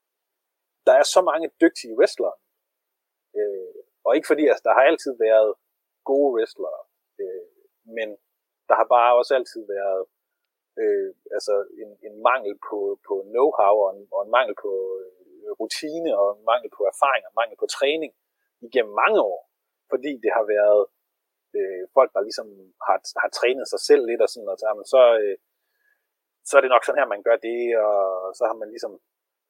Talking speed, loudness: 175 wpm, -22 LUFS